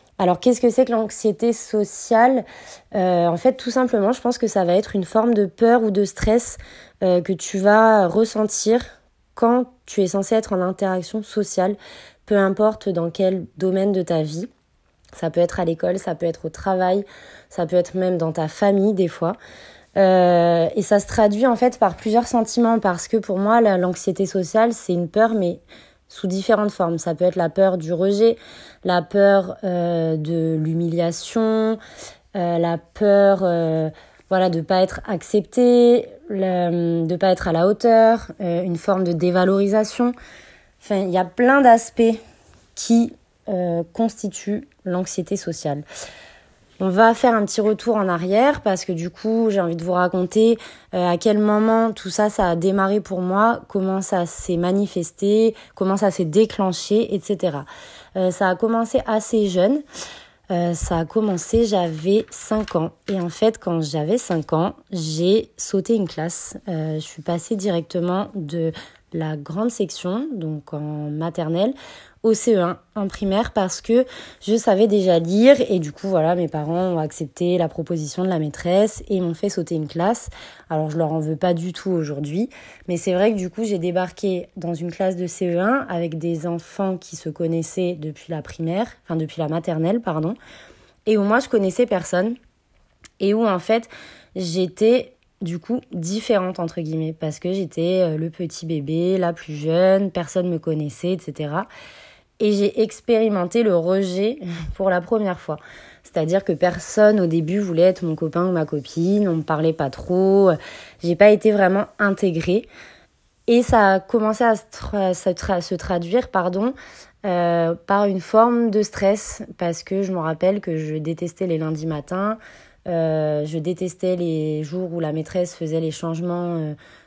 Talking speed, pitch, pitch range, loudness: 175 wpm, 185 Hz, 170-215 Hz, -20 LUFS